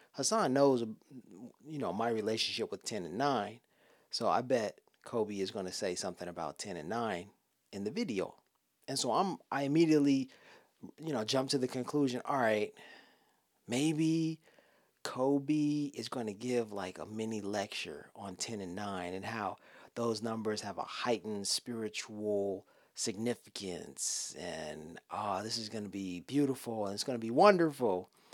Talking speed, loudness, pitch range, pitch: 165 wpm, -35 LUFS, 105-135 Hz, 115 Hz